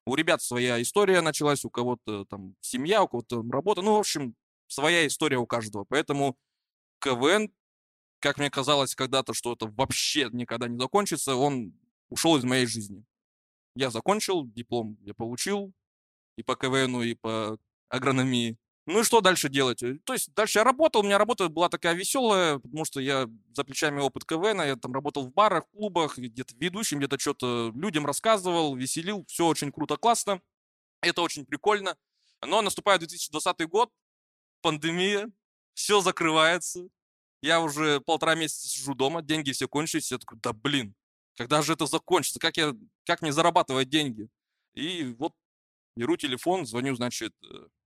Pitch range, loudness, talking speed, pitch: 125-175 Hz, -27 LUFS, 160 wpm, 145 Hz